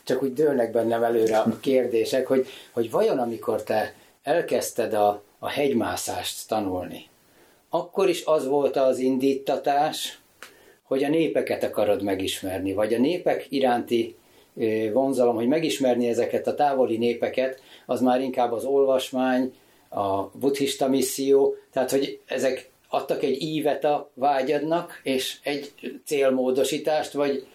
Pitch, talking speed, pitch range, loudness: 130 Hz, 130 wpm, 115-140 Hz, -24 LUFS